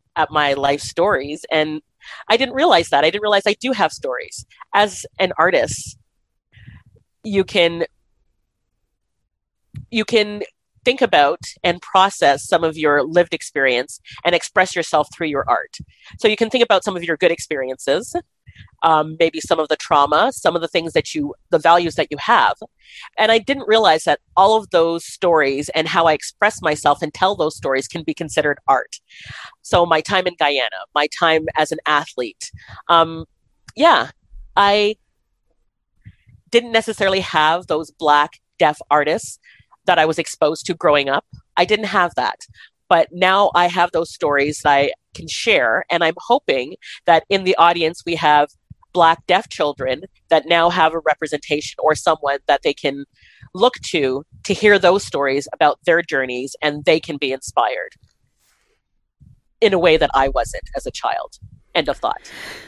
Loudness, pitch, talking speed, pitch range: -17 LUFS, 160 Hz, 170 wpm, 145-185 Hz